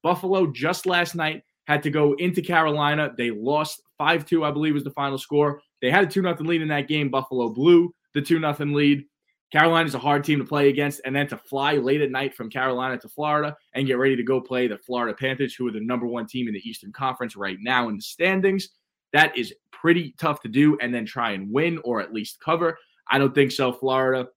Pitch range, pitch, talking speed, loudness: 130-160 Hz, 145 Hz, 240 wpm, -23 LUFS